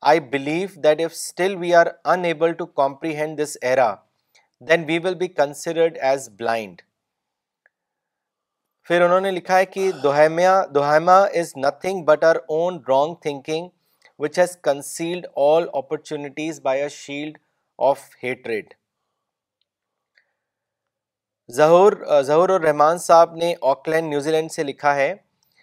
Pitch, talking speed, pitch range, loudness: 160 Hz, 130 wpm, 145-175 Hz, -20 LUFS